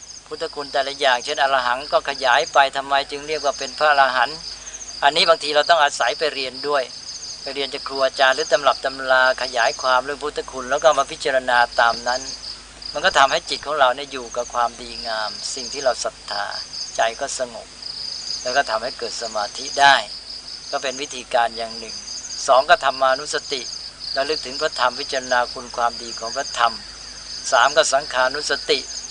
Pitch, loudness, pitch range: 135 Hz, -20 LUFS, 125-145 Hz